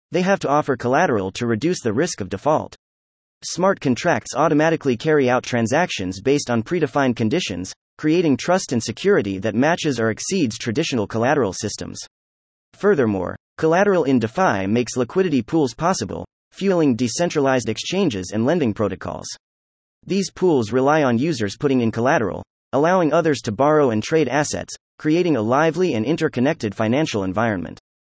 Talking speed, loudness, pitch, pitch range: 145 wpm, -20 LUFS, 125 Hz, 110-160 Hz